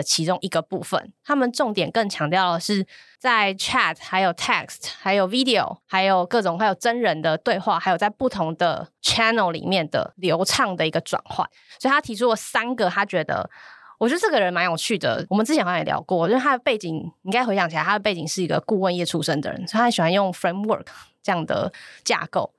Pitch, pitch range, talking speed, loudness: 195 Hz, 175-230 Hz, 380 characters per minute, -22 LUFS